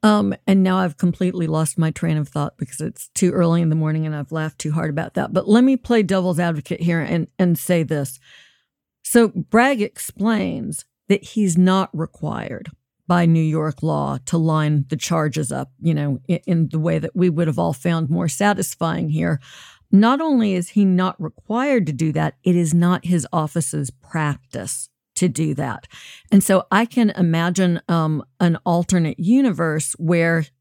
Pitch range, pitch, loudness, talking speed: 155-185 Hz, 170 Hz, -20 LUFS, 185 wpm